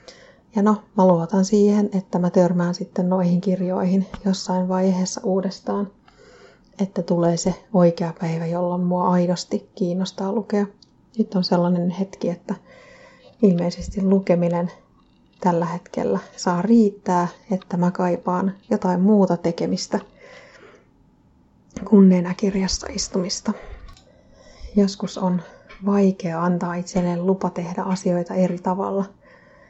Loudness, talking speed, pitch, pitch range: -21 LUFS, 110 wpm, 185 Hz, 180-195 Hz